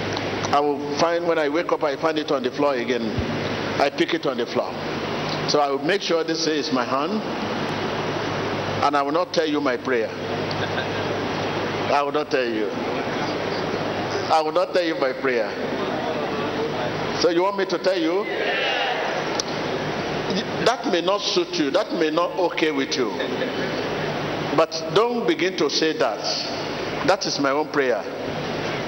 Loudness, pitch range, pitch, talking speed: -23 LUFS, 145-175 Hz, 160 Hz, 160 wpm